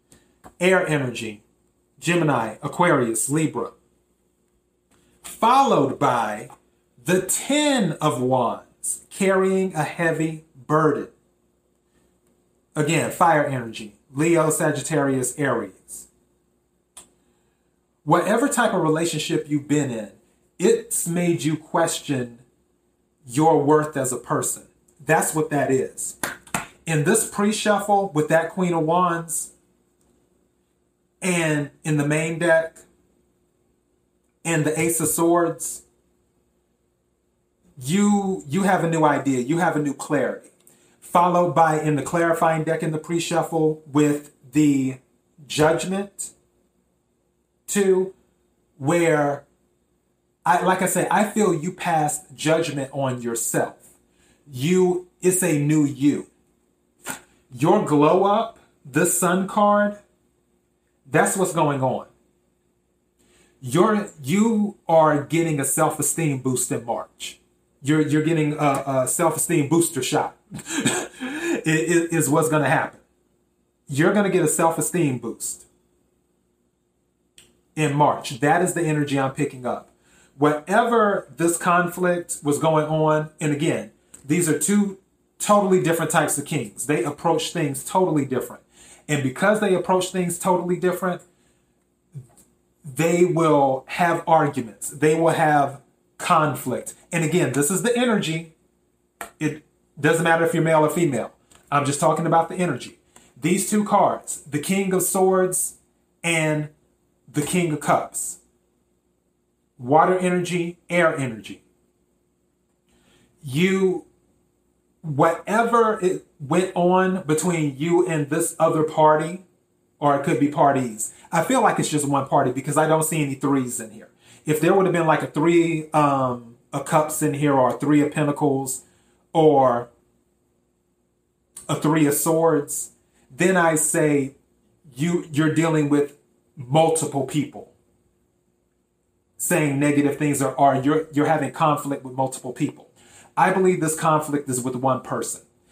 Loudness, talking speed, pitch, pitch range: -21 LUFS, 125 wpm, 150 Hz, 120-170 Hz